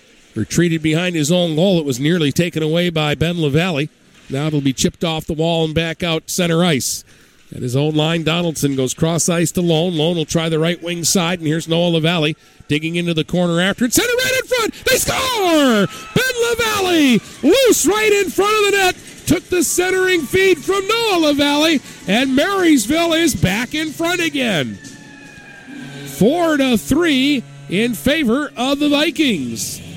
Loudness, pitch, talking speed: -16 LUFS, 185 Hz, 180 wpm